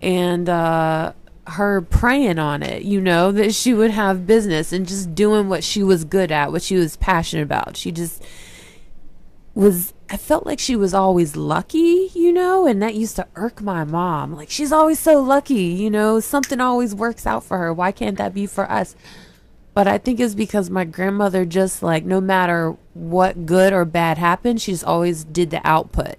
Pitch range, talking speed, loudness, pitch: 175-220 Hz, 195 wpm, -18 LUFS, 190 Hz